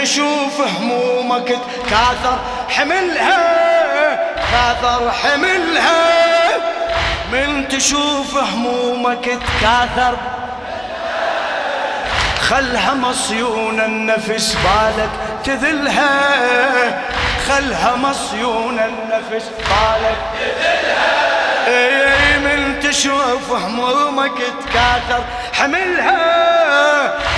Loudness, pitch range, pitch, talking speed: -15 LUFS, 245-290 Hz, 255 Hz, 55 wpm